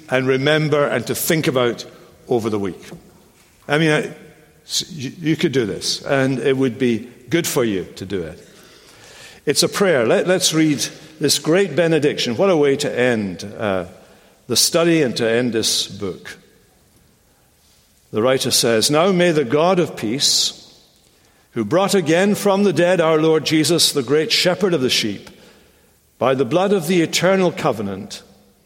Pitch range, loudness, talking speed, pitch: 120-170 Hz, -17 LUFS, 165 wpm, 145 Hz